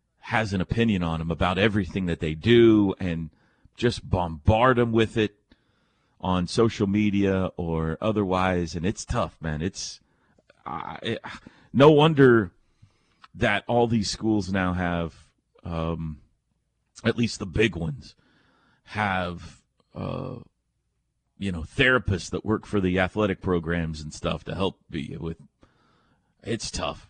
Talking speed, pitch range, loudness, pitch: 135 wpm, 85-110 Hz, -24 LUFS, 95 Hz